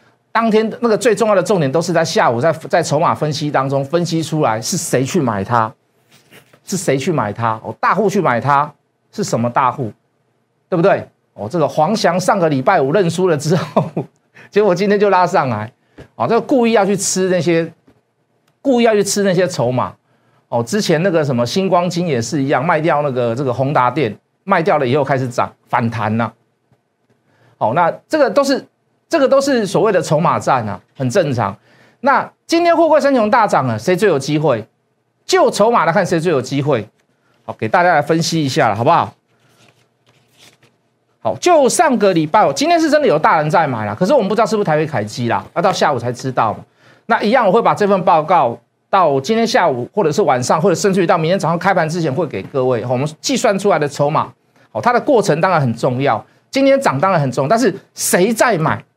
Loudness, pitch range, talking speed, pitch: -15 LUFS, 135-205 Hz, 305 characters per minute, 165 Hz